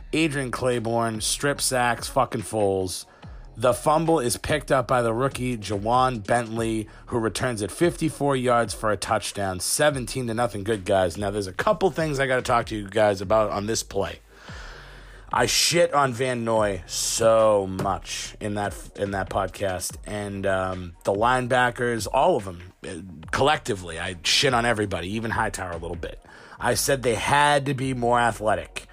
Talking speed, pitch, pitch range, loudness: 170 wpm, 115 Hz, 100-130 Hz, -24 LUFS